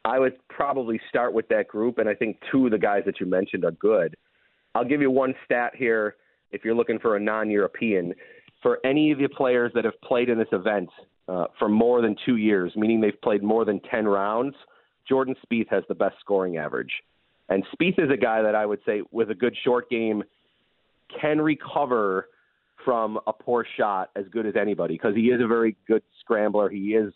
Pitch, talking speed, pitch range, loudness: 115 Hz, 210 wpm, 105-130 Hz, -24 LUFS